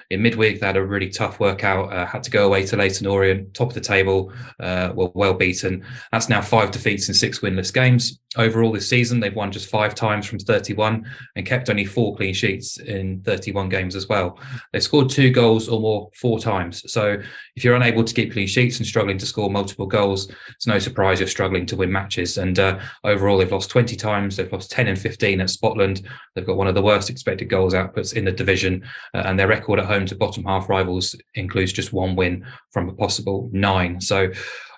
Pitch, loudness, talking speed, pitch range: 100 Hz, -20 LUFS, 220 wpm, 95-115 Hz